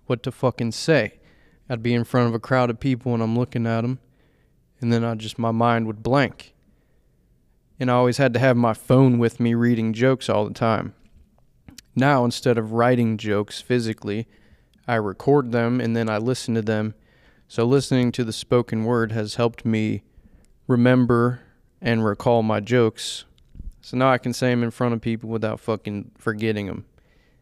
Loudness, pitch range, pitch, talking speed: -22 LUFS, 110-125 Hz, 115 Hz, 185 wpm